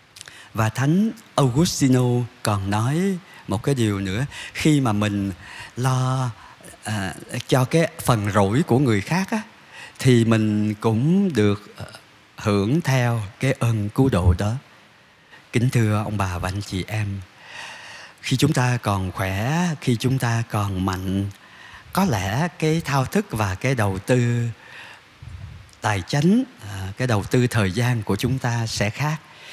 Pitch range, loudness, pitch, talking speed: 105-135 Hz, -22 LUFS, 120 Hz, 145 wpm